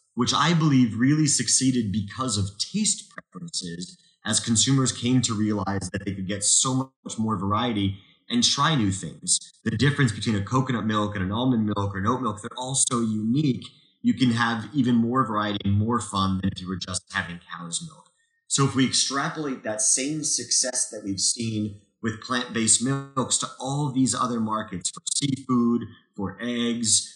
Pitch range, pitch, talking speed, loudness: 105-130 Hz, 115 Hz, 190 wpm, -24 LUFS